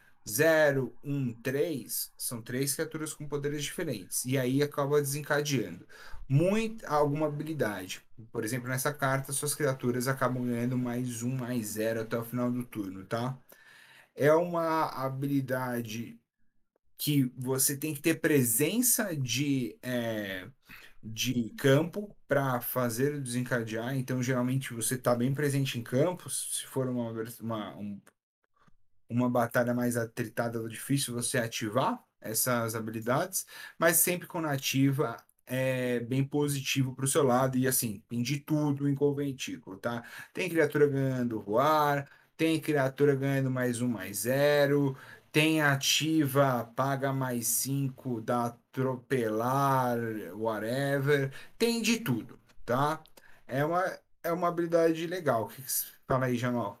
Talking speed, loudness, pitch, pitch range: 135 wpm, -30 LUFS, 130 Hz, 120-145 Hz